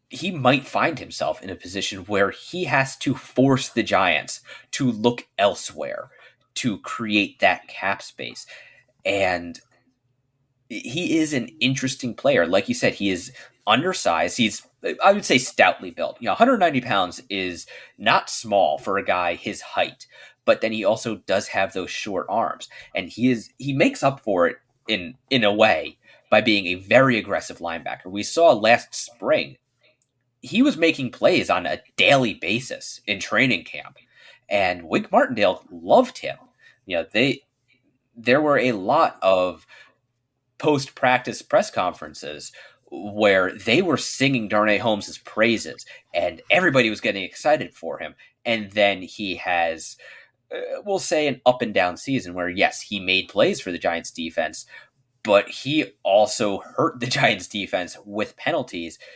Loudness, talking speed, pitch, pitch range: -22 LUFS, 160 wpm, 125 Hz, 100-135 Hz